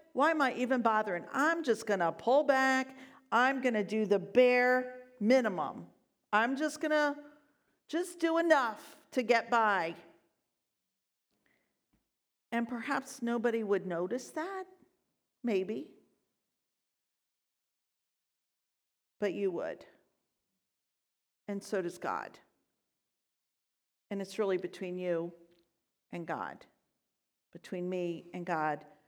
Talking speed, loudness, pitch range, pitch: 105 wpm, -32 LUFS, 190-270 Hz, 235 Hz